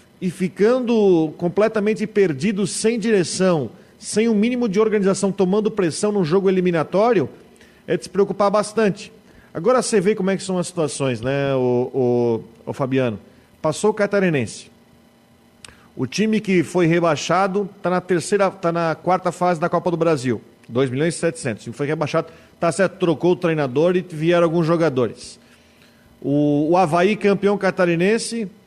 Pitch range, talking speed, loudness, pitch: 155-205 Hz, 160 wpm, -19 LUFS, 180 Hz